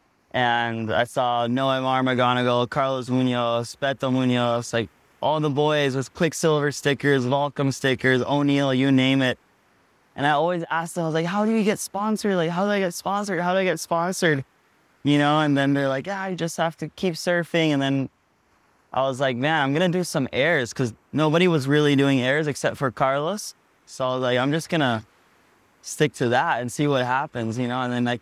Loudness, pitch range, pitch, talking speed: -23 LUFS, 130-165 Hz, 140 Hz, 215 wpm